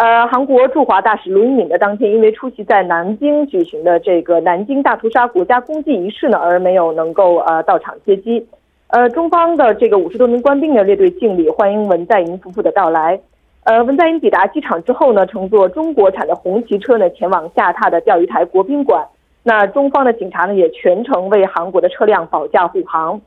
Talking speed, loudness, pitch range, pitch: 325 characters per minute, -13 LUFS, 185-285 Hz, 225 Hz